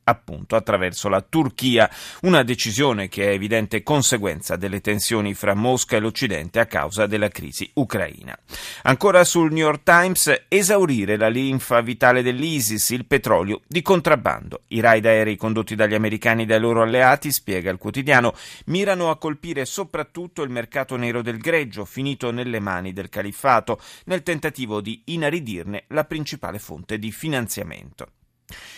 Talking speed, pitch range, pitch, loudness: 145 wpm, 105-150 Hz, 120 Hz, -20 LUFS